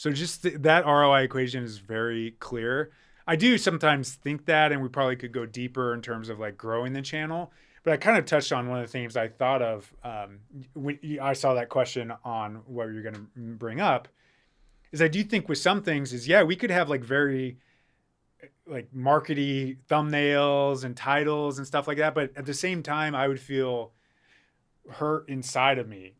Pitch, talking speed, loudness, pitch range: 135 Hz, 200 wpm, -26 LUFS, 120-150 Hz